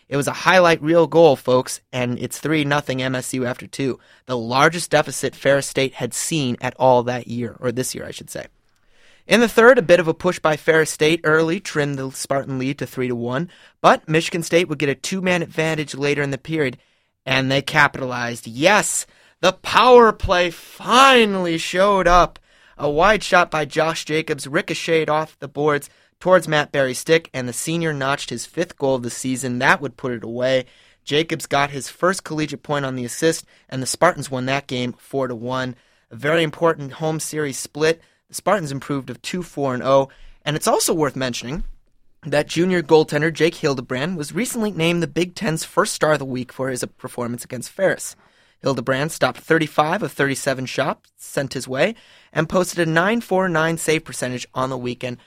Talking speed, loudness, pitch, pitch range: 190 wpm, -19 LUFS, 145 Hz, 130-165 Hz